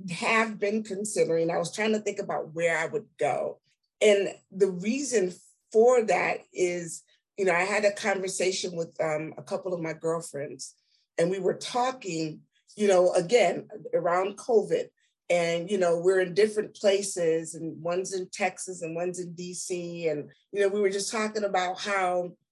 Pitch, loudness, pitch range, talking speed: 185 Hz, -27 LUFS, 170-205 Hz, 175 wpm